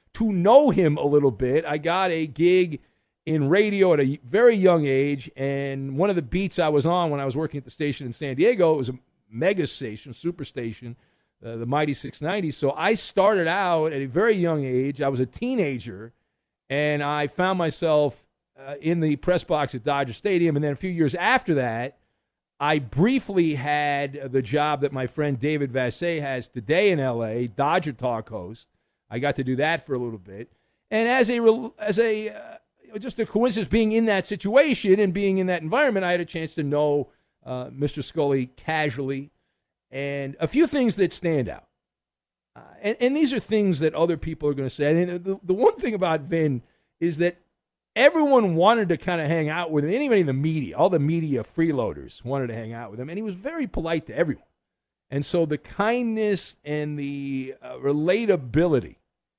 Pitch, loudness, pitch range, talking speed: 155 Hz, -23 LUFS, 135-185 Hz, 200 wpm